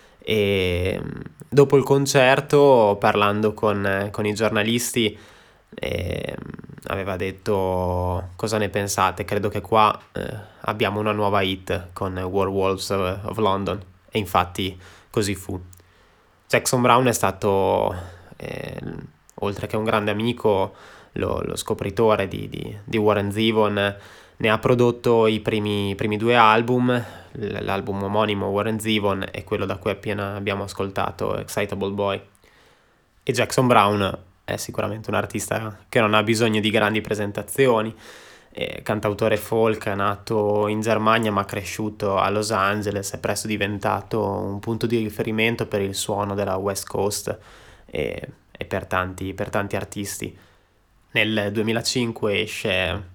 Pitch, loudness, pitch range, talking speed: 105 Hz, -22 LUFS, 100-110 Hz, 135 wpm